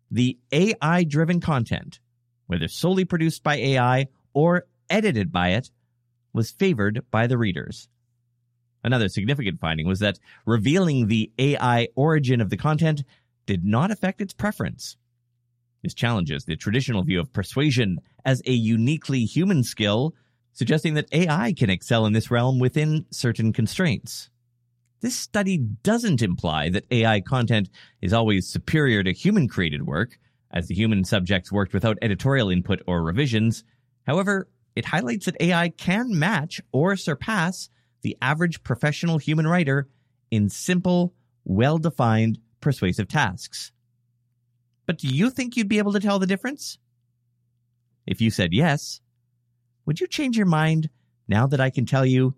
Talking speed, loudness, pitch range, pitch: 145 wpm, -23 LUFS, 115-160 Hz, 125 Hz